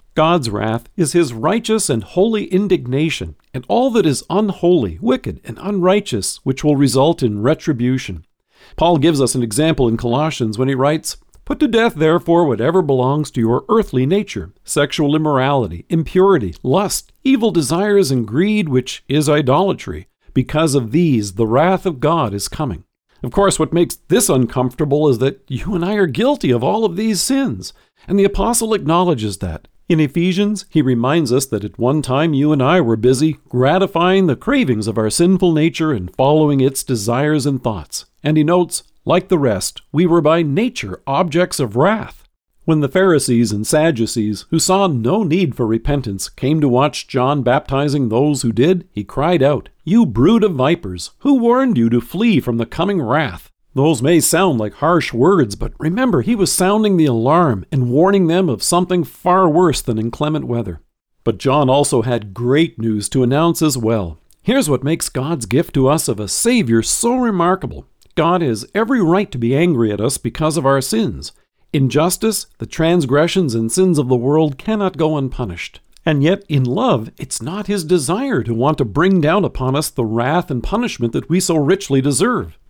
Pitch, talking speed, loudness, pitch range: 150 Hz, 185 wpm, -16 LUFS, 125-180 Hz